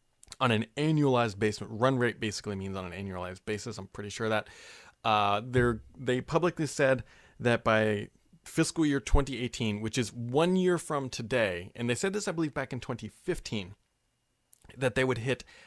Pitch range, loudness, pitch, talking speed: 110-135 Hz, -30 LUFS, 120 Hz, 170 wpm